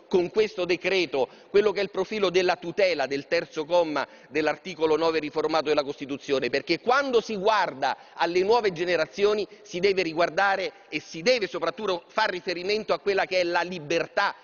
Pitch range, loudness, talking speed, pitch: 165-200 Hz, -25 LUFS, 165 wpm, 180 Hz